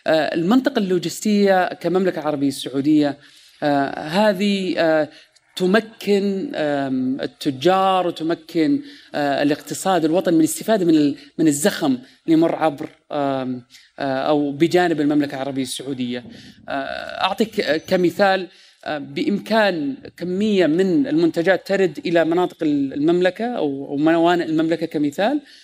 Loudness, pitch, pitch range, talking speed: -20 LUFS, 175 Hz, 150-205 Hz, 85 wpm